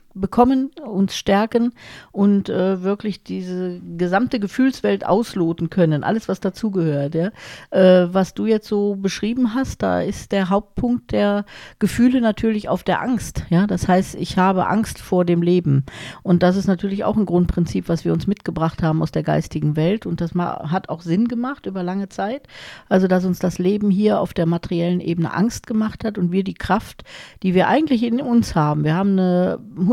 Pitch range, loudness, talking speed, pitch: 175-215 Hz, -20 LUFS, 185 wpm, 190 Hz